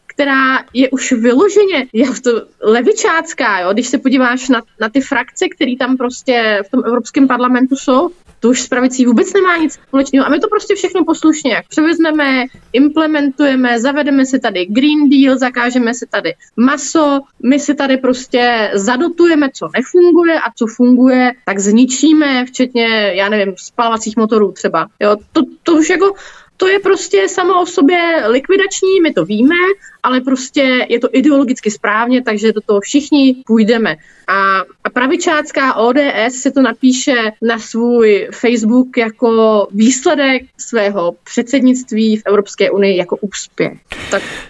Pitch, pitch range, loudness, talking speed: 255 Hz, 230-295 Hz, -12 LUFS, 150 wpm